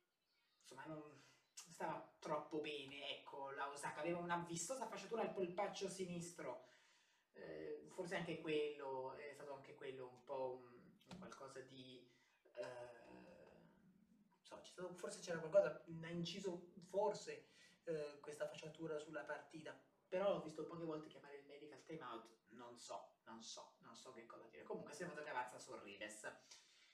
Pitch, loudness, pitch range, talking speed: 155 Hz, -49 LUFS, 135-185 Hz, 150 wpm